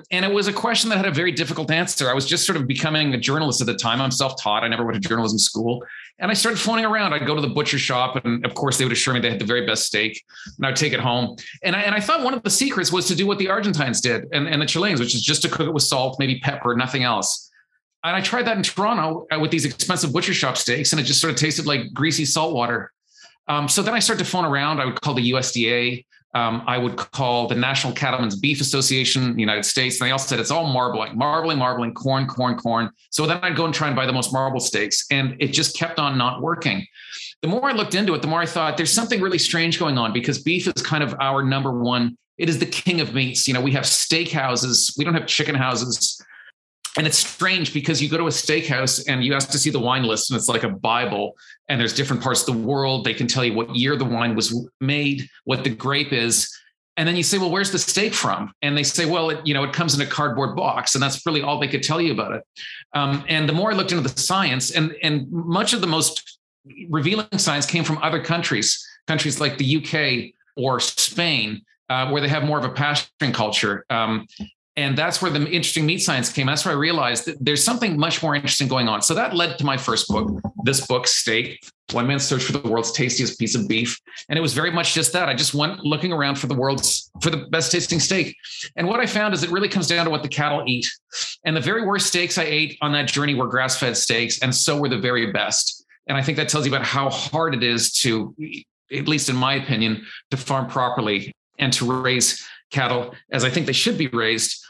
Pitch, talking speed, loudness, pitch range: 145 Hz, 255 wpm, -20 LUFS, 125-165 Hz